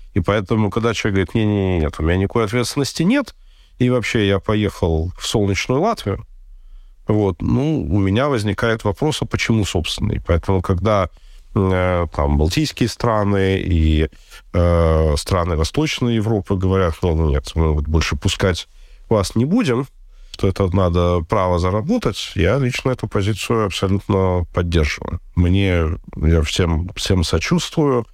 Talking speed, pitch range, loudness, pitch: 145 wpm, 85-110 Hz, -19 LUFS, 95 Hz